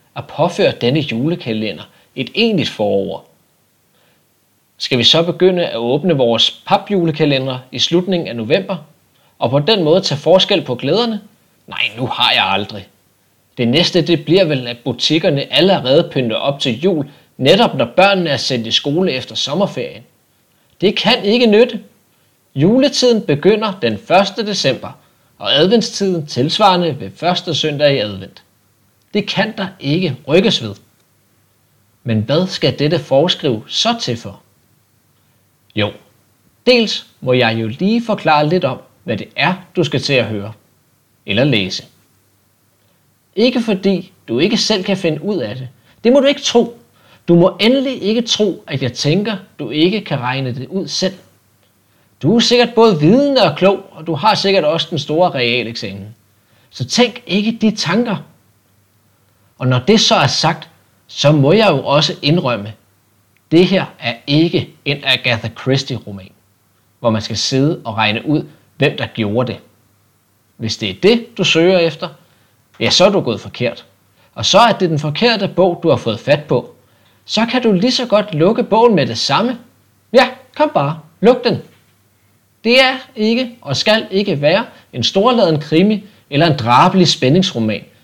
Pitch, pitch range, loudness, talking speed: 150 Hz, 115-195 Hz, -14 LUFS, 165 wpm